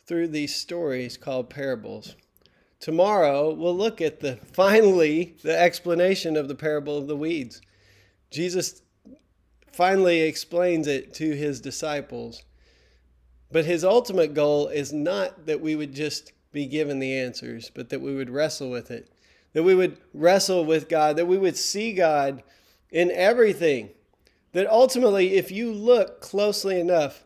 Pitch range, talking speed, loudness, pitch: 140-180 Hz, 150 wpm, -23 LUFS, 155 Hz